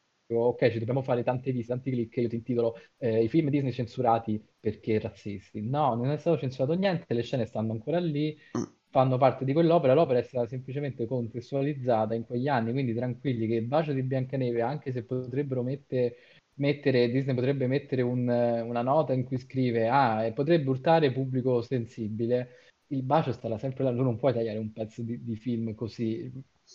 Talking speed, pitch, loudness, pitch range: 185 wpm, 125 Hz, -28 LUFS, 115-135 Hz